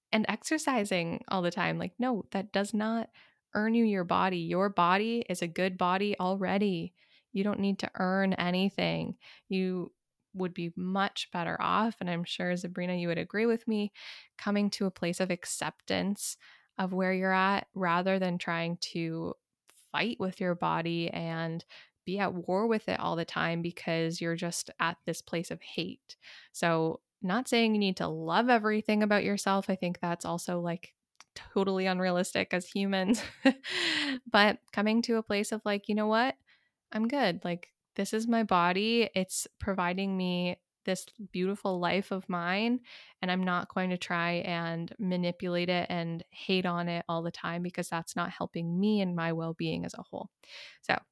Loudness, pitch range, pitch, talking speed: -31 LUFS, 175-205 Hz, 185 Hz, 175 wpm